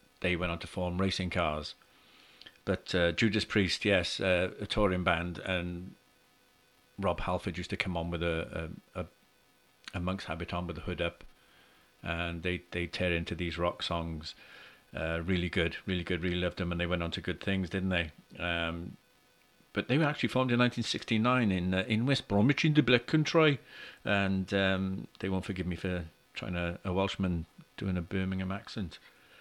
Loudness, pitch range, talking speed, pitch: -32 LUFS, 85-100 Hz, 190 wpm, 90 Hz